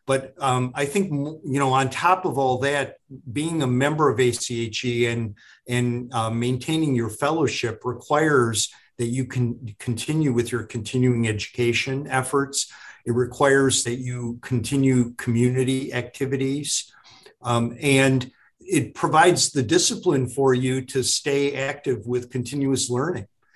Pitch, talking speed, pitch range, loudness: 130 Hz, 135 wpm, 120-140 Hz, -23 LUFS